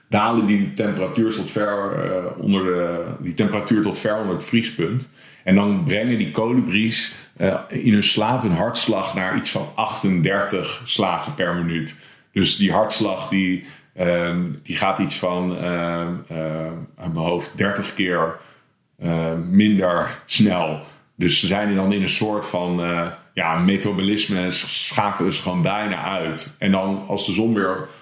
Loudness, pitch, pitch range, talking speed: -21 LUFS, 95 Hz, 85-105 Hz, 165 wpm